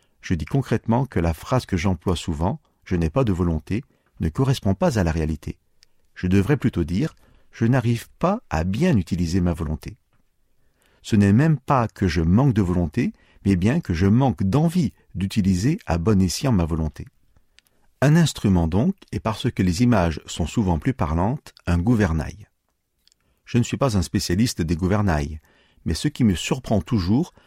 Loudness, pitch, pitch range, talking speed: -22 LUFS, 100 Hz, 85-120 Hz, 175 wpm